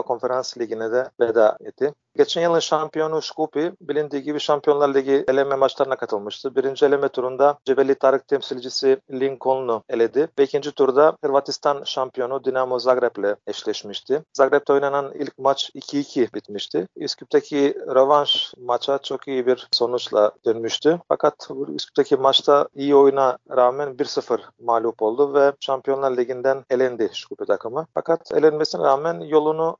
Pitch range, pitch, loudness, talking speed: 130-150 Hz, 140 Hz, -21 LUFS, 130 wpm